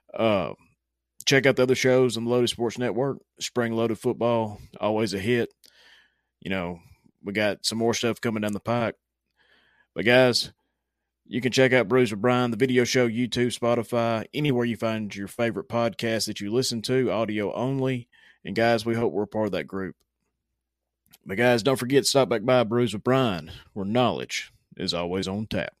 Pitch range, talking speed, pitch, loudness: 105-125 Hz, 185 wpm, 115 Hz, -25 LUFS